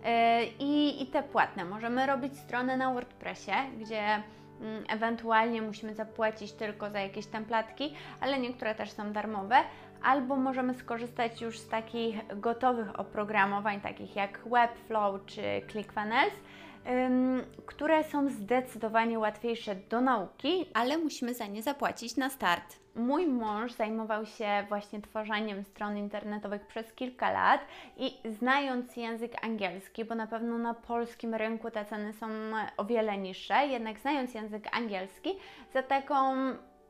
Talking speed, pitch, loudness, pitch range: 130 wpm, 225 Hz, -32 LUFS, 215-255 Hz